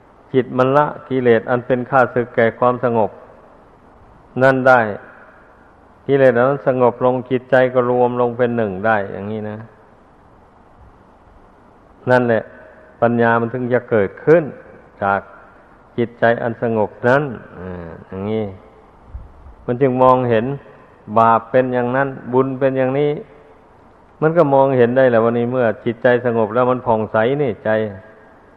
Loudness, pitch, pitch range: -16 LUFS, 120 Hz, 110-130 Hz